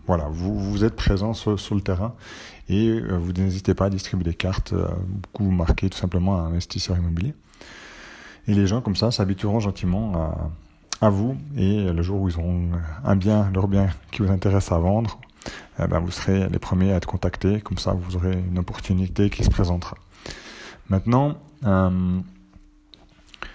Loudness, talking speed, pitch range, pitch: -23 LUFS, 180 wpm, 90-100 Hz, 95 Hz